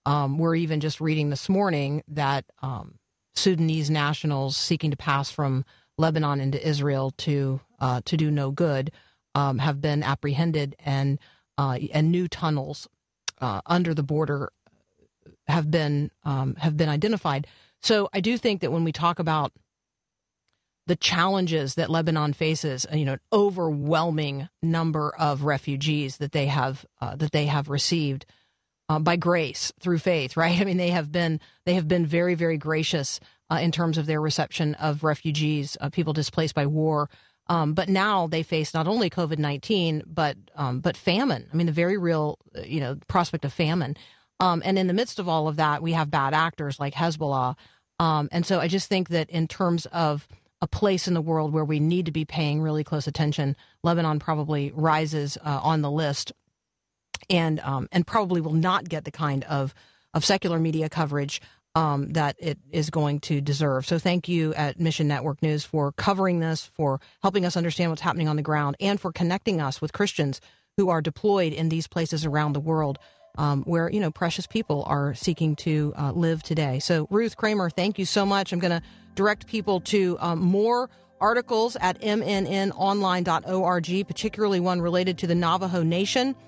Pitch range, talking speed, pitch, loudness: 145-175 Hz, 180 wpm, 160 Hz, -25 LUFS